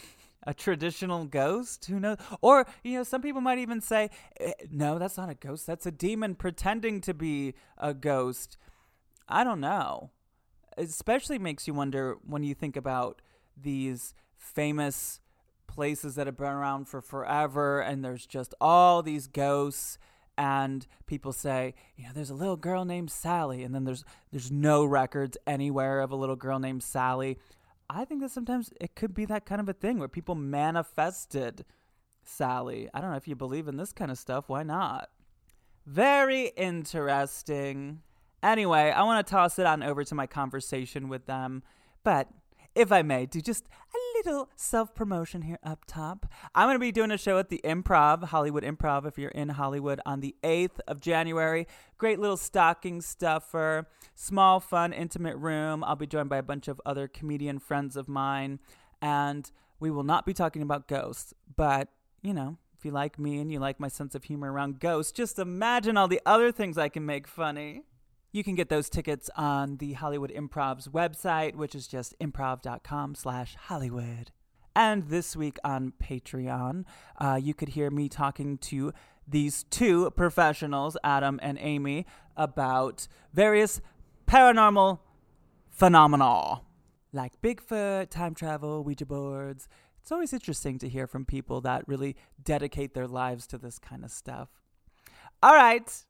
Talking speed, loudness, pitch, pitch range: 170 wpm, -28 LUFS, 145 Hz, 135-175 Hz